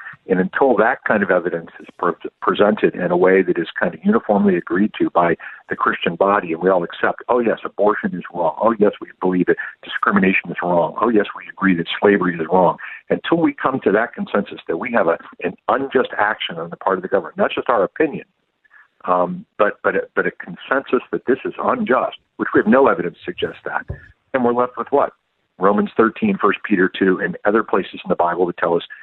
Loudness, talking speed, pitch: -18 LUFS, 220 wpm, 100 Hz